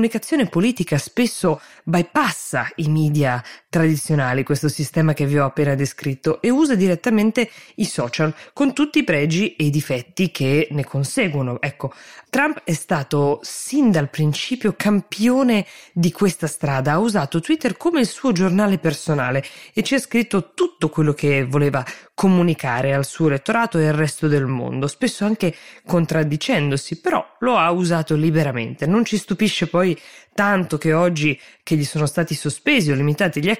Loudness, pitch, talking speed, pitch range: -20 LUFS, 165 Hz, 160 wpm, 145-210 Hz